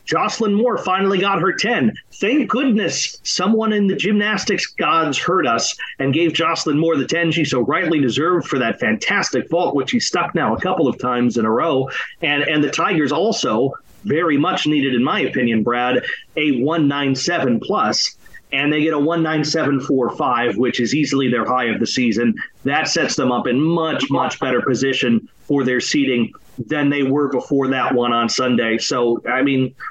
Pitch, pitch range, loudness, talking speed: 145 Hz, 125-170 Hz, -18 LUFS, 195 wpm